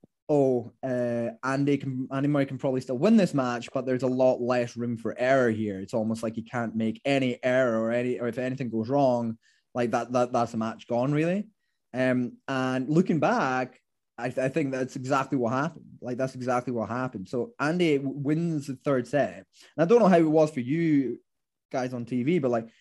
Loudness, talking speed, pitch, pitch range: -27 LUFS, 215 wpm, 130 Hz, 120-140 Hz